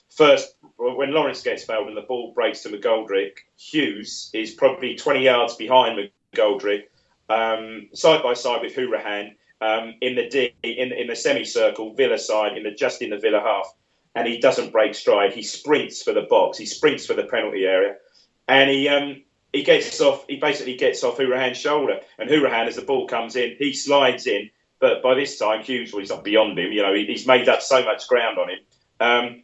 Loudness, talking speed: -21 LUFS, 205 wpm